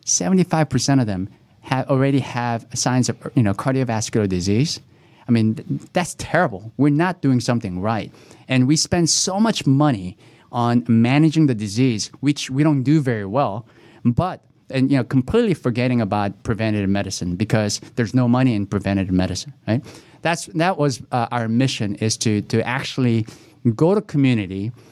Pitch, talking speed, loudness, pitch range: 125 Hz, 160 wpm, -20 LUFS, 110-145 Hz